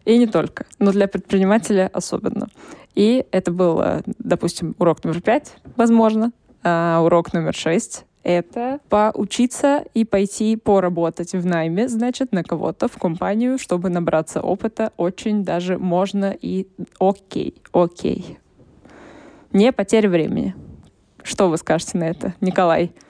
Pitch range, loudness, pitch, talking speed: 175-225 Hz, -20 LUFS, 195 Hz, 125 wpm